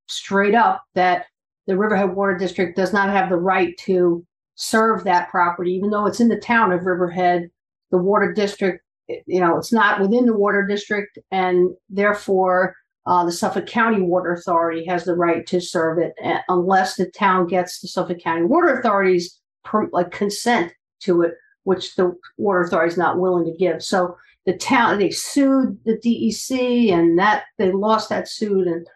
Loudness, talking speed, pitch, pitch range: -19 LUFS, 175 wpm, 185 Hz, 180-205 Hz